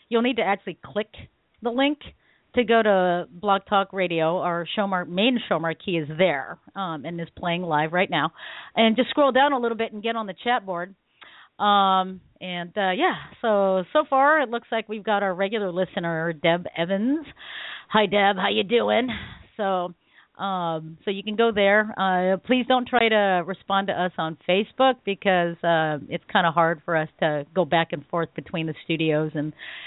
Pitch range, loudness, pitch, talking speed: 170-220 Hz, -23 LUFS, 190 Hz, 195 wpm